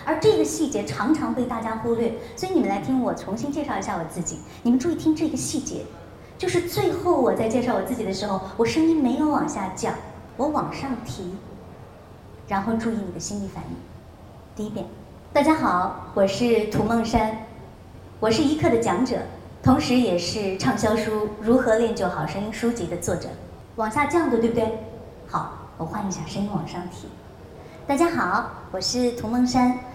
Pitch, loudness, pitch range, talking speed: 230 Hz, -24 LUFS, 200-275 Hz, 270 characters per minute